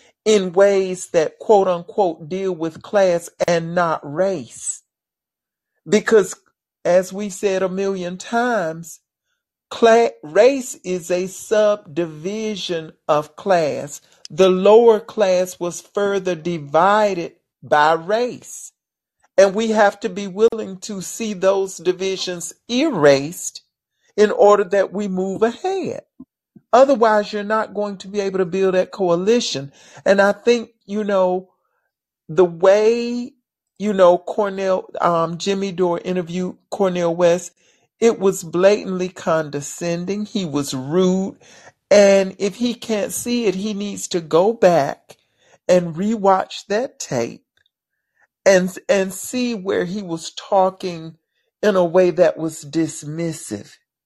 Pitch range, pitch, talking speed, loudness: 175-210 Hz, 190 Hz, 125 wpm, -18 LUFS